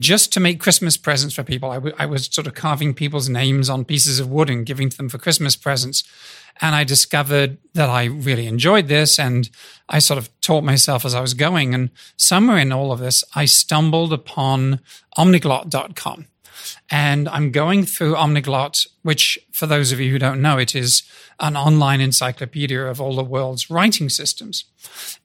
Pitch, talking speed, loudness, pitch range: 145 Hz, 185 wpm, -17 LUFS, 130-155 Hz